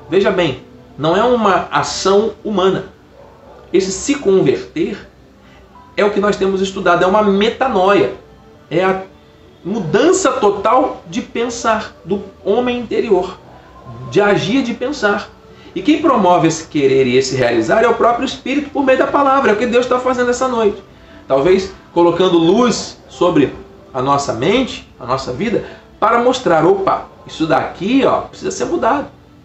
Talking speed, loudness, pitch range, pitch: 155 wpm, -15 LUFS, 170-250 Hz, 200 Hz